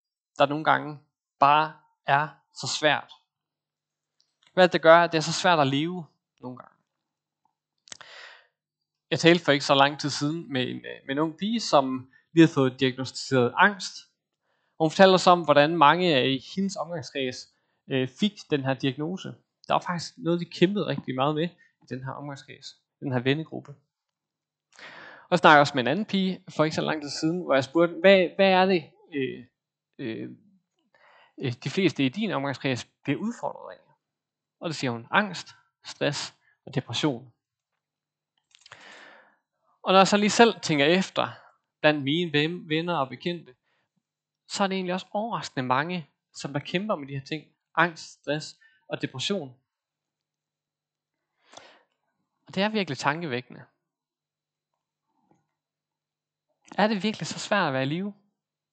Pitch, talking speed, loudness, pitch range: 155 Hz, 155 wpm, -24 LUFS, 140-180 Hz